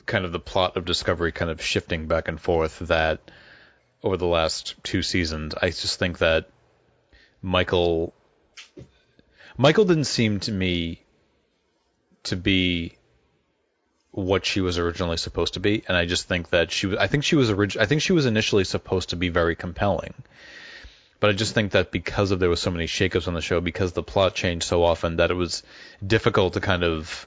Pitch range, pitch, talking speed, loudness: 85-105 Hz, 90 Hz, 190 wpm, -23 LUFS